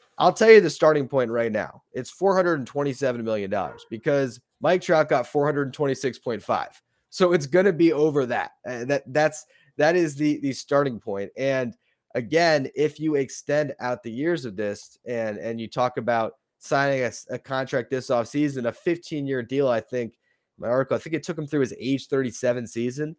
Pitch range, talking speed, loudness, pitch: 125-155 Hz, 200 wpm, -24 LUFS, 135 Hz